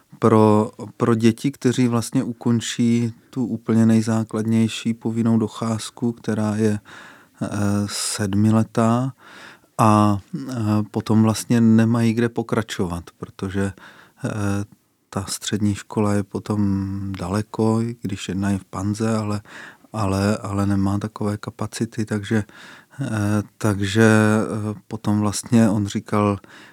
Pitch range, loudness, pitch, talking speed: 105-115 Hz, -21 LUFS, 110 Hz, 100 wpm